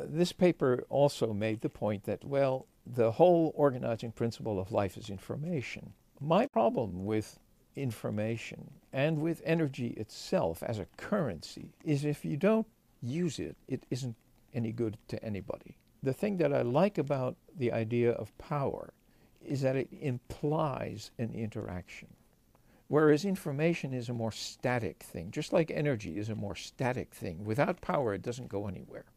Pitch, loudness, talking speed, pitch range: 125 Hz, -33 LUFS, 155 wpm, 110-150 Hz